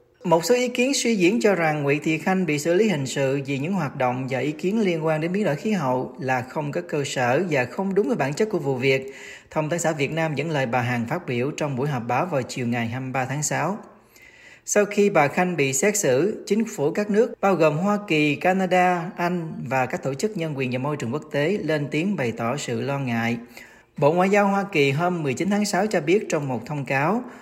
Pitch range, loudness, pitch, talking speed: 135-195 Hz, -23 LUFS, 155 Hz, 250 wpm